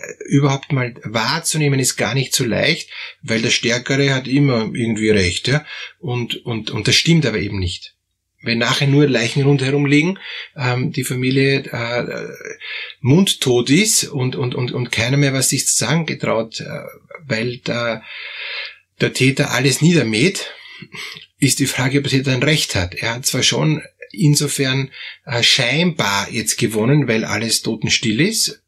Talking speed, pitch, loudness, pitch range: 155 wpm, 135 Hz, -17 LUFS, 120-145 Hz